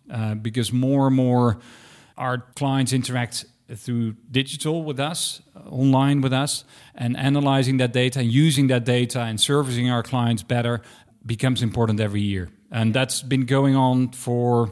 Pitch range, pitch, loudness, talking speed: 120-135 Hz, 125 Hz, -22 LUFS, 160 wpm